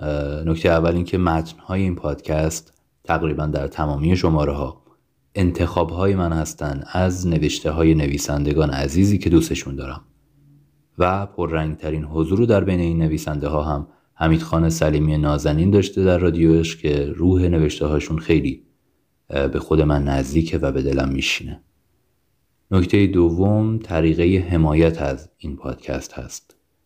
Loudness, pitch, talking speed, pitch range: -20 LUFS, 80 Hz, 140 wpm, 75-90 Hz